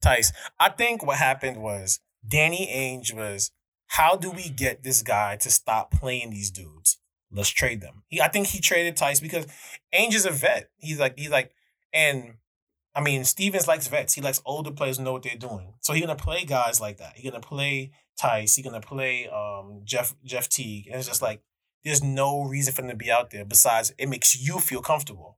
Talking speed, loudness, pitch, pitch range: 210 wpm, -24 LUFS, 130 Hz, 110-145 Hz